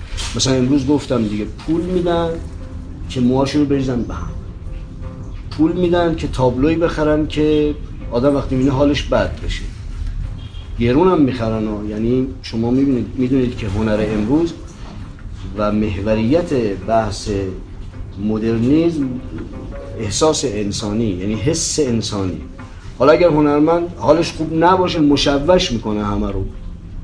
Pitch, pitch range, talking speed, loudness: 110 Hz, 95-145 Hz, 120 wpm, -17 LUFS